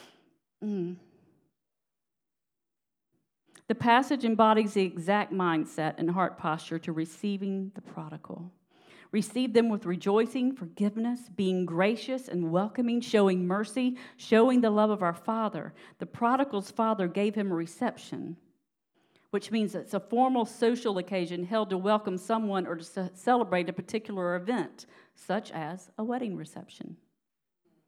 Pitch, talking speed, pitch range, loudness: 200 Hz, 130 wpm, 180-225 Hz, -29 LUFS